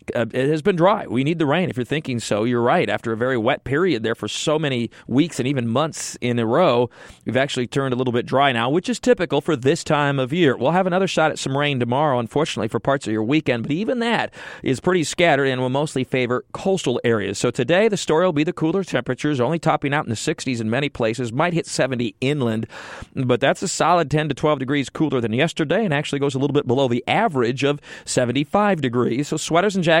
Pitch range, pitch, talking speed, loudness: 125-160 Hz, 140 Hz, 245 wpm, -20 LUFS